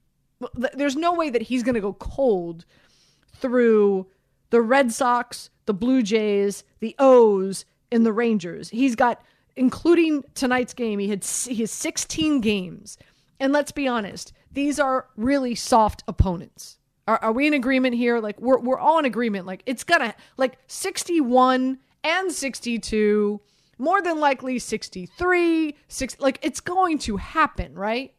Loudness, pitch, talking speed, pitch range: -22 LUFS, 250 Hz, 145 wpm, 215-280 Hz